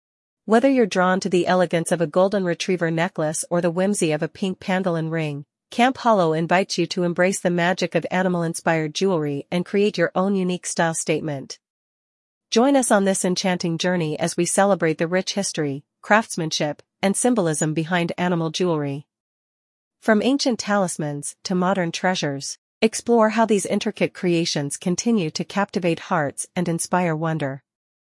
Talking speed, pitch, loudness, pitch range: 160 wpm, 180 Hz, -21 LUFS, 160-195 Hz